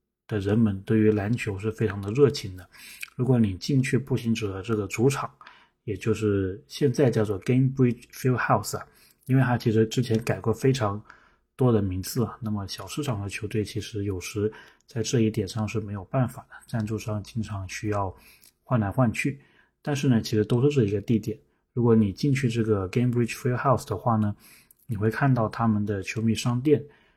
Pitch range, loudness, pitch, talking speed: 105-125 Hz, -26 LUFS, 110 Hz, 350 characters per minute